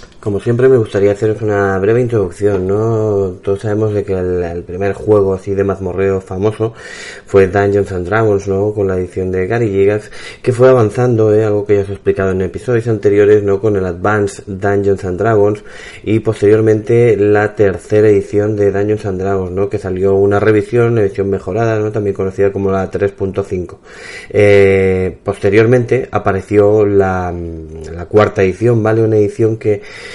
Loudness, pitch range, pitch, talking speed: -13 LUFS, 95-110 Hz, 100 Hz, 170 wpm